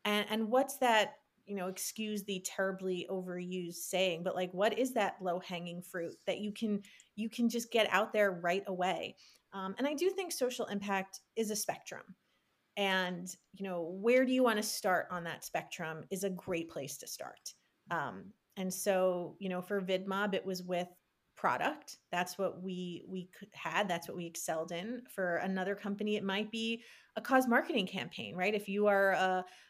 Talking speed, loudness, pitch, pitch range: 190 wpm, -35 LUFS, 195 Hz, 180-215 Hz